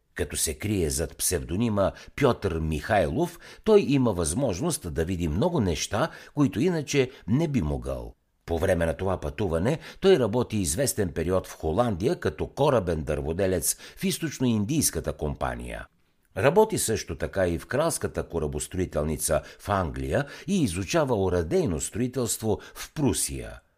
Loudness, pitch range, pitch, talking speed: -26 LUFS, 80-120 Hz, 90 Hz, 130 wpm